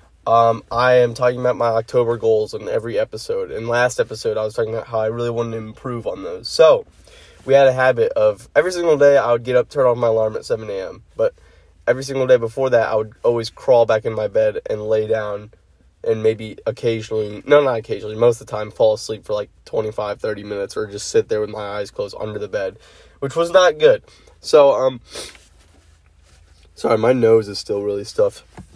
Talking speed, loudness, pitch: 215 wpm, -18 LUFS, 130 Hz